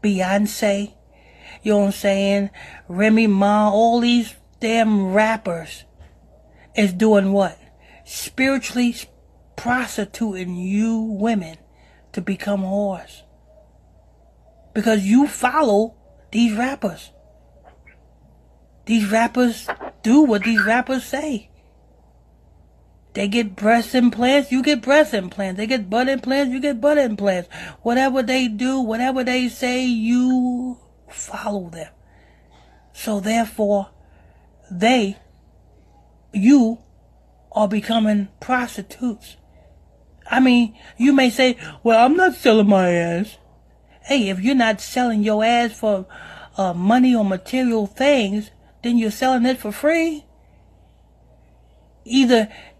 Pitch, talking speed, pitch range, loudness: 220 Hz, 110 wpm, 195-250 Hz, -19 LUFS